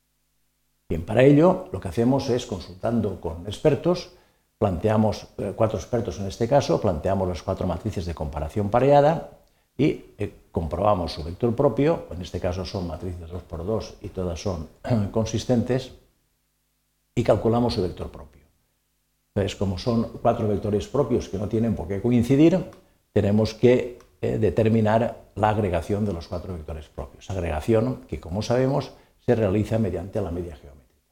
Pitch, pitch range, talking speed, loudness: 105 Hz, 90-115 Hz, 150 wpm, -24 LUFS